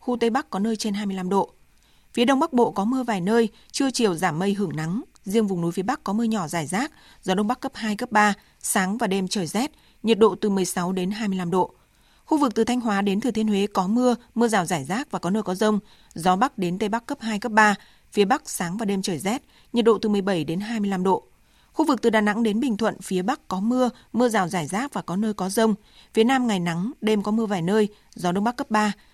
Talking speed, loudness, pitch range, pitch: 265 wpm, -23 LUFS, 195-235 Hz, 215 Hz